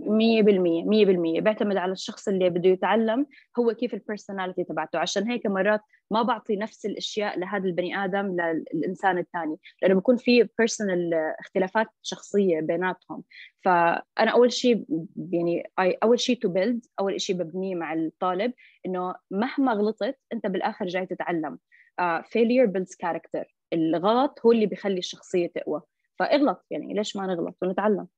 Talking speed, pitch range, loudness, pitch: 145 wpm, 180-225 Hz, -25 LUFS, 195 Hz